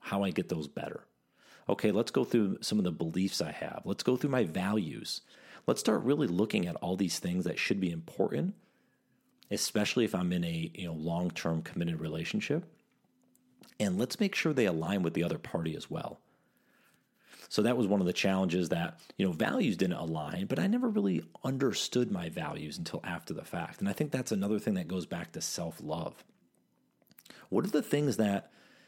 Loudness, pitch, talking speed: -33 LUFS, 100 Hz, 195 wpm